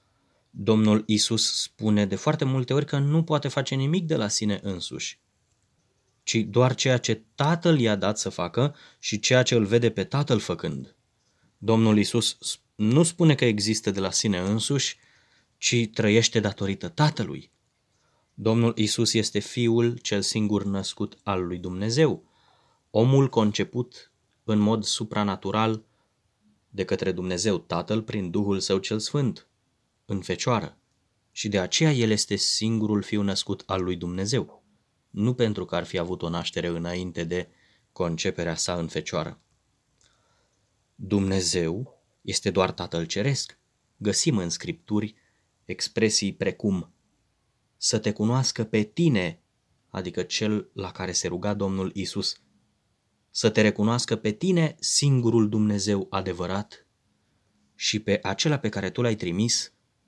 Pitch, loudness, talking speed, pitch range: 105 Hz, -25 LUFS, 135 wpm, 95-120 Hz